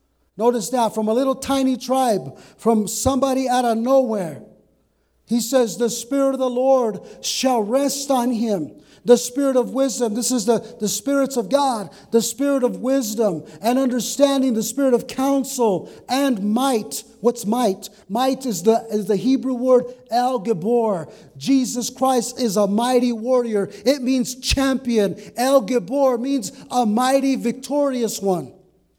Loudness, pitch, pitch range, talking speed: -20 LUFS, 245 Hz, 225-260 Hz, 150 wpm